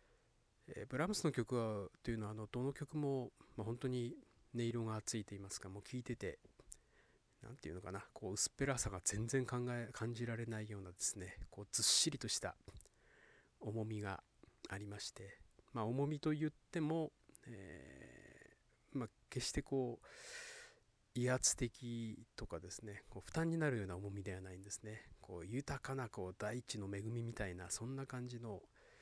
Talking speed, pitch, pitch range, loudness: 325 characters per minute, 115 Hz, 100-130 Hz, -43 LUFS